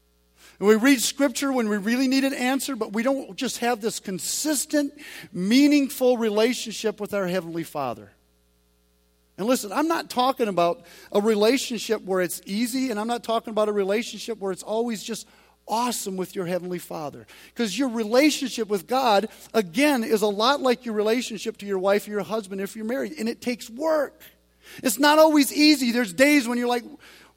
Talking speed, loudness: 185 wpm, -23 LUFS